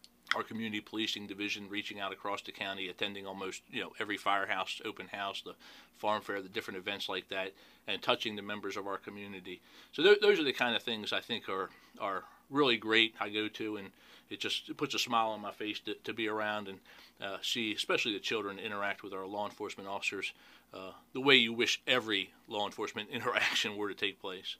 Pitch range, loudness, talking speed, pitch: 100-115 Hz, -34 LUFS, 210 wpm, 105 Hz